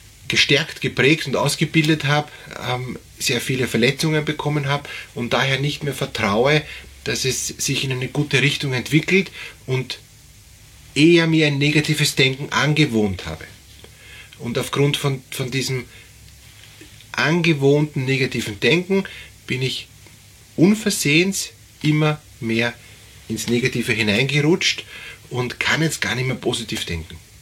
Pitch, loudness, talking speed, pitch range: 130 Hz, -19 LUFS, 120 wpm, 115-150 Hz